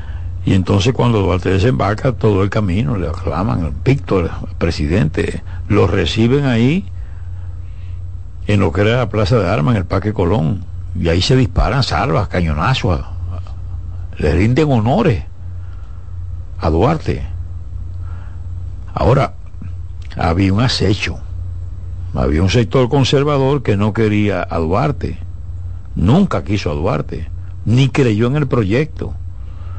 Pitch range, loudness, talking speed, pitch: 90-110 Hz, -16 LUFS, 125 wpm, 90 Hz